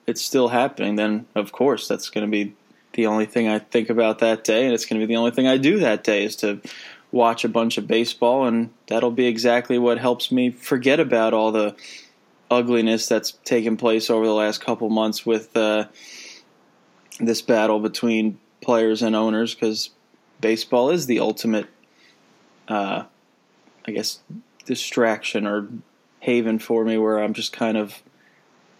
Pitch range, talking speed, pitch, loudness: 110-120 Hz, 175 wpm, 115 Hz, -21 LUFS